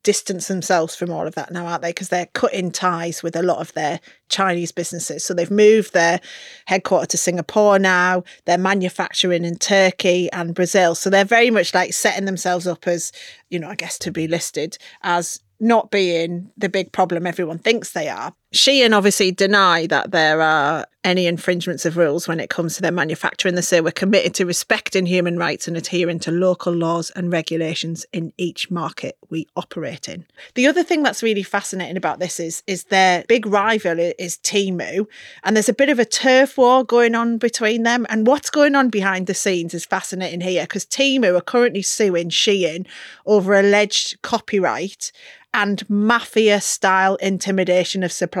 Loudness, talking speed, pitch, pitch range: -18 LUFS, 185 wpm, 185 Hz, 175-205 Hz